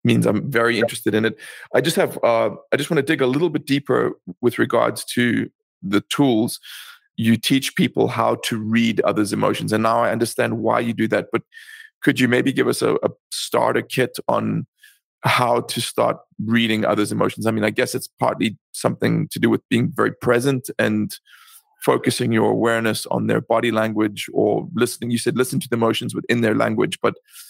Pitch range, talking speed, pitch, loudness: 110-125 Hz, 195 wpm, 115 Hz, -20 LUFS